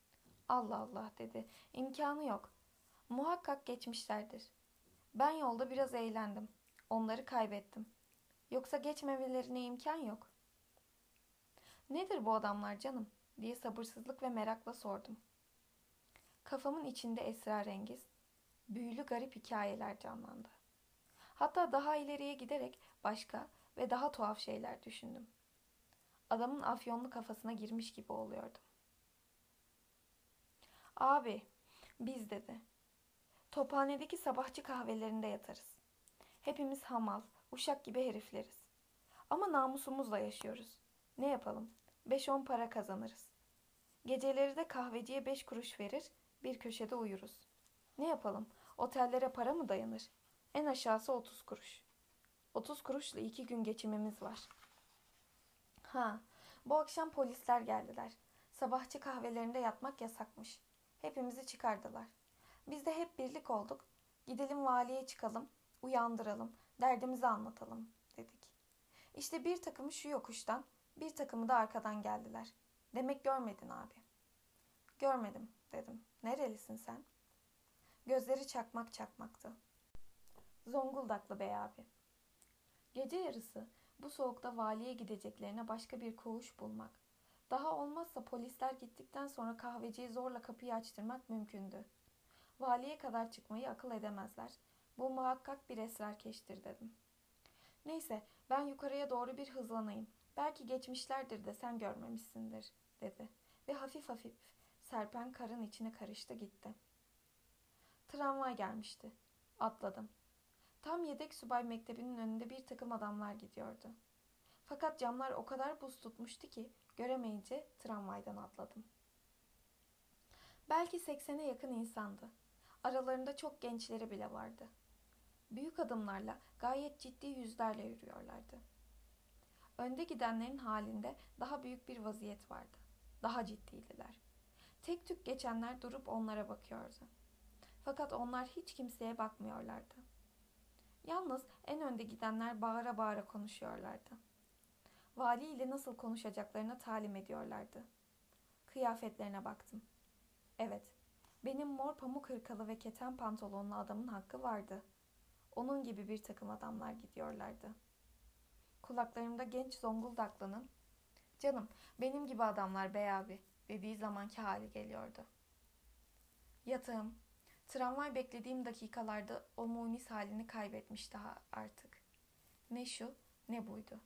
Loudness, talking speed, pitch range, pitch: -44 LUFS, 105 wpm, 215-265 Hz, 235 Hz